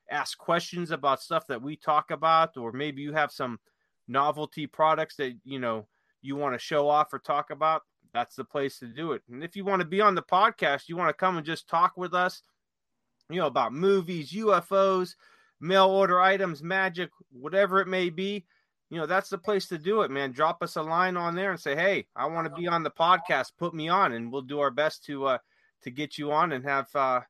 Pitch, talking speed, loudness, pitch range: 160 Hz, 230 wpm, -27 LUFS, 145-185 Hz